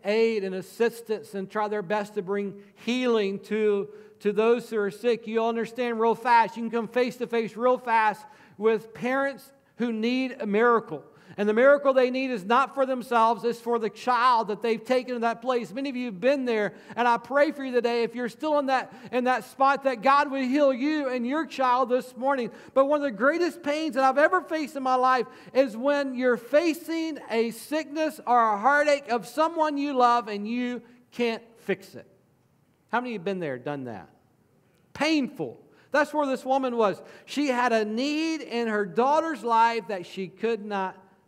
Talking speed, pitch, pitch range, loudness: 205 wpm, 240 Hz, 215-270 Hz, -25 LUFS